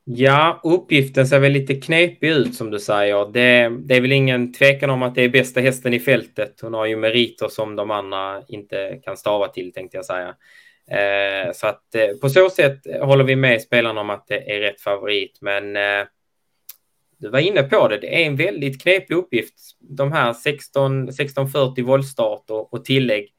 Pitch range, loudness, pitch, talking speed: 110-140 Hz, -18 LUFS, 125 Hz, 190 wpm